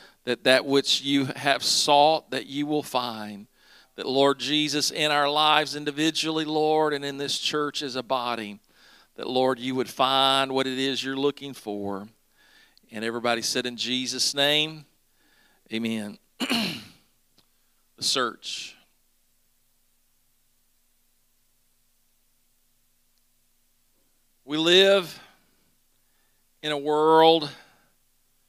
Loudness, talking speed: -24 LUFS, 105 wpm